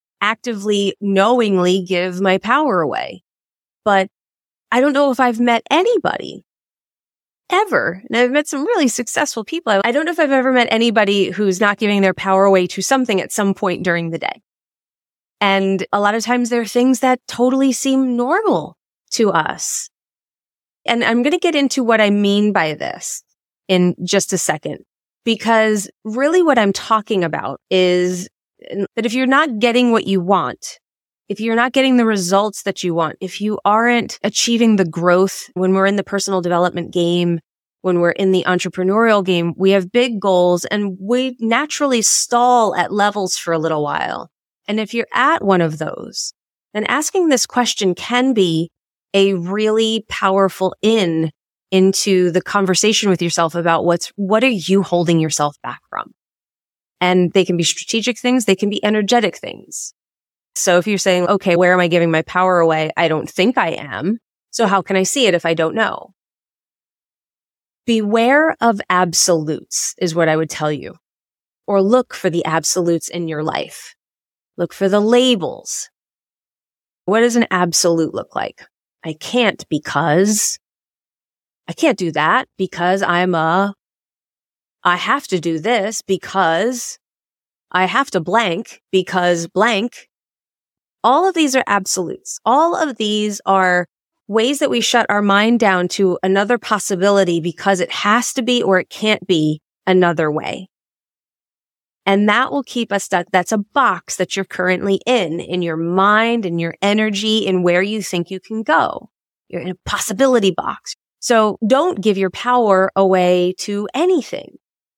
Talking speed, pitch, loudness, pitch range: 165 wpm, 195 Hz, -16 LUFS, 180-230 Hz